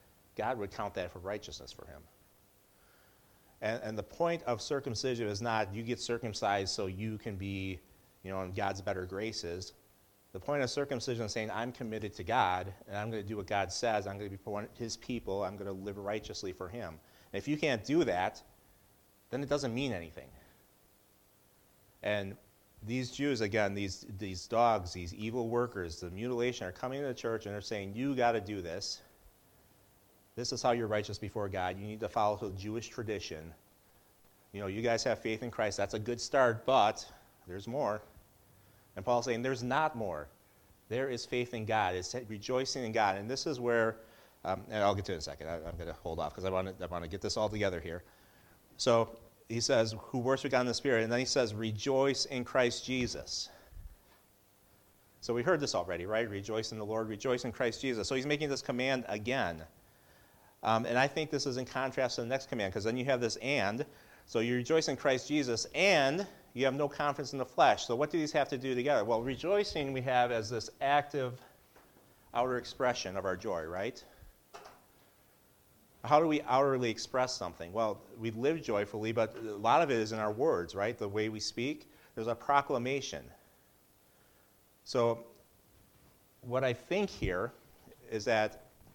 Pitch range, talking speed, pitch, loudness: 100-125 Hz, 200 wpm, 115 Hz, -34 LUFS